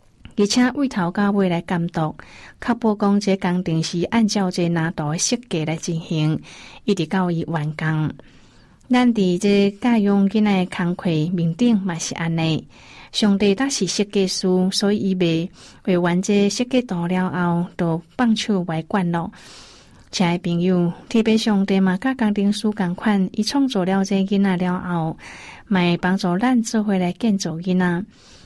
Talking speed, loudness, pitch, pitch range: 230 characters per minute, -20 LUFS, 185 Hz, 175-210 Hz